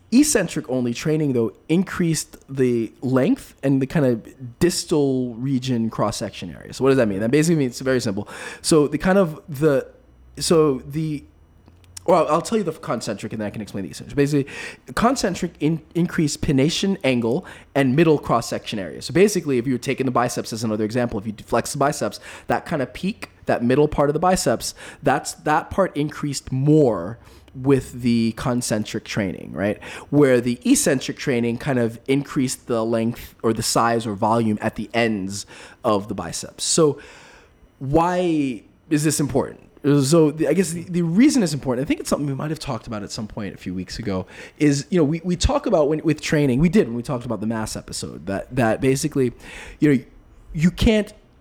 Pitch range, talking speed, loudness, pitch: 115-160 Hz, 200 wpm, -21 LUFS, 135 Hz